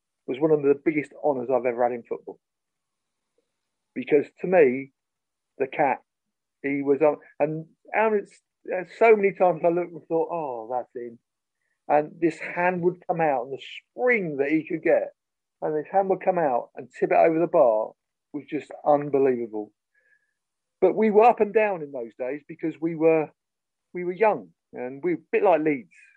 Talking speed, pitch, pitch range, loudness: 185 wpm, 165 Hz, 140-205 Hz, -24 LUFS